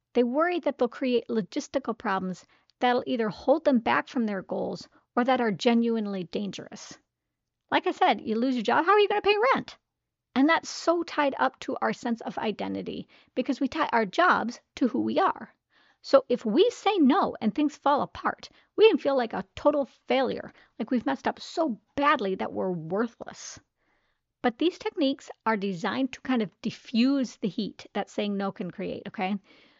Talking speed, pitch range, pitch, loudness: 190 wpm, 220-290 Hz, 250 Hz, -27 LUFS